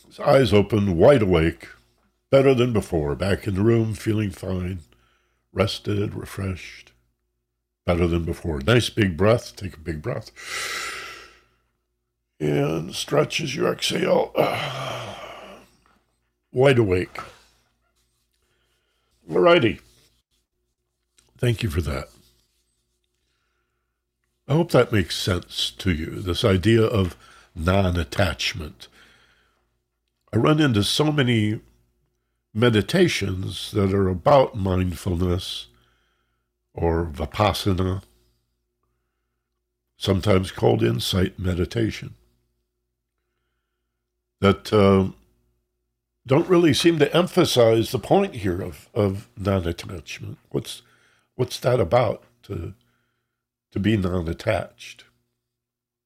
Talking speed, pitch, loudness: 90 wpm, 90 Hz, -22 LUFS